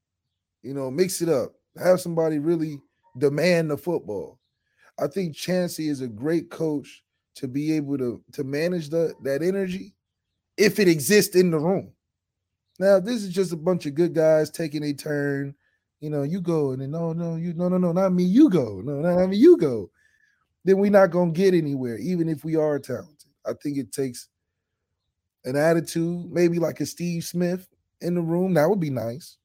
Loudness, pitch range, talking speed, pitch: -23 LUFS, 140-180 Hz, 195 wpm, 160 Hz